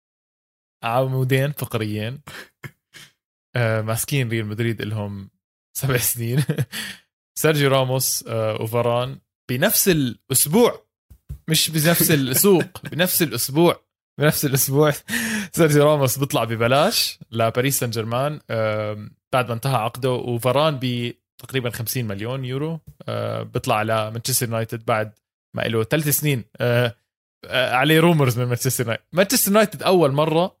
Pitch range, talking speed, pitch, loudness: 115-150 Hz, 105 wpm, 130 Hz, -20 LUFS